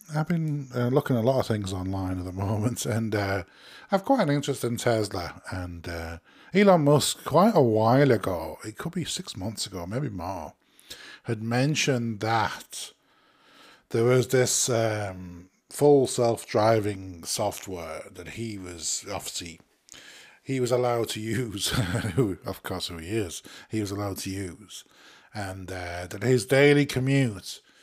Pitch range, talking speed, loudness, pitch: 95-130 Hz, 155 wpm, -26 LUFS, 115 Hz